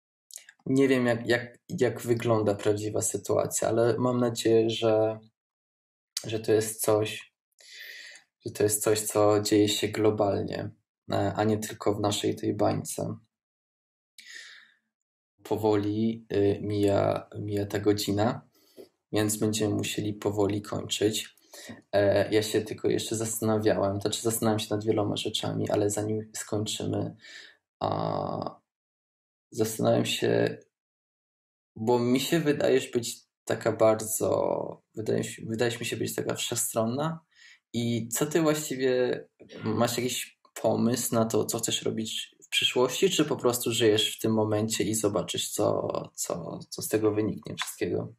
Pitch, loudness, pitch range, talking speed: 110 Hz, -27 LUFS, 105-120 Hz, 130 wpm